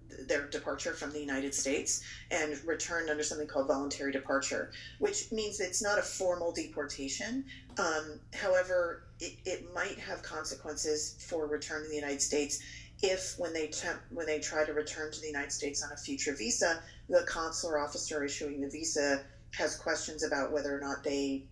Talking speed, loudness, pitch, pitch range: 175 wpm, -34 LUFS, 150 Hz, 140-165 Hz